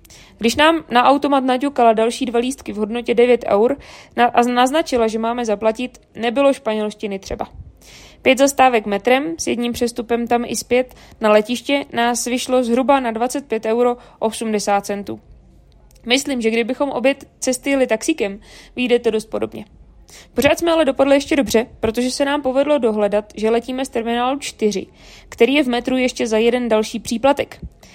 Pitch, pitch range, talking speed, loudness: 240 Hz, 220-260 Hz, 160 wpm, -18 LUFS